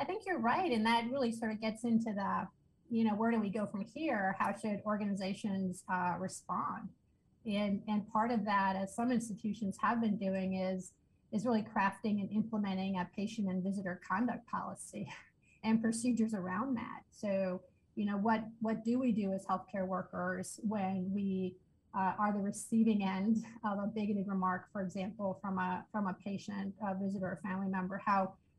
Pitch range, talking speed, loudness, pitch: 190-220 Hz, 185 wpm, -36 LUFS, 205 Hz